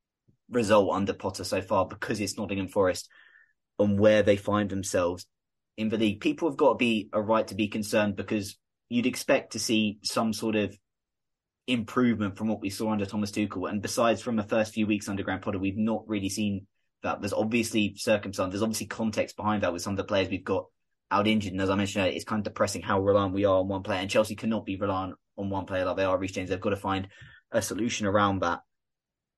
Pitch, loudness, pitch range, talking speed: 100 Hz, -28 LUFS, 95-110 Hz, 225 wpm